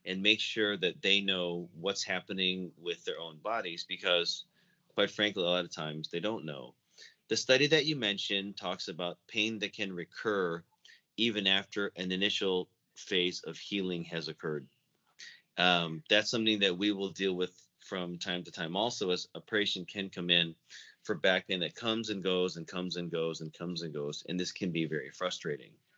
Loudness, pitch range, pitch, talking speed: -32 LUFS, 85-105 Hz, 95 Hz, 190 wpm